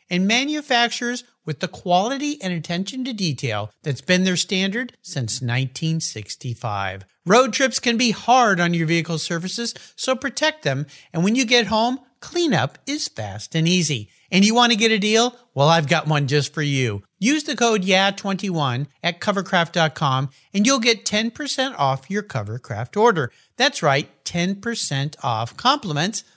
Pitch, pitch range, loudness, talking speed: 180 Hz, 145-235 Hz, -20 LUFS, 160 wpm